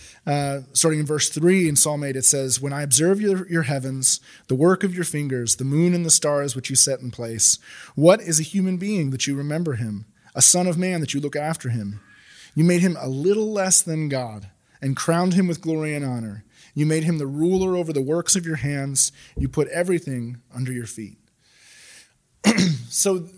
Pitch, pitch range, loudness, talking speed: 150 Hz, 130-175 Hz, -20 LUFS, 210 wpm